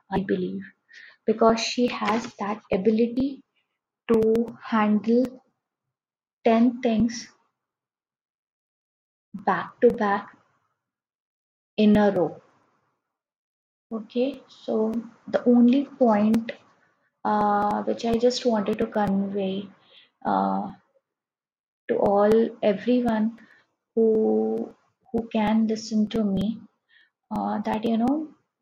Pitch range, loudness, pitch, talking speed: 210-240 Hz, -24 LUFS, 225 Hz, 90 wpm